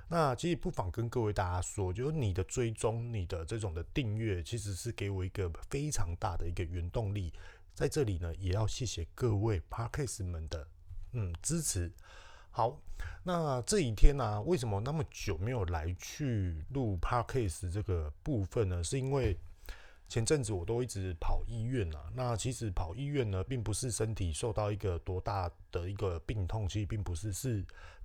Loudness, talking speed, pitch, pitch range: -36 LUFS, 285 characters per minute, 100 Hz, 90-120 Hz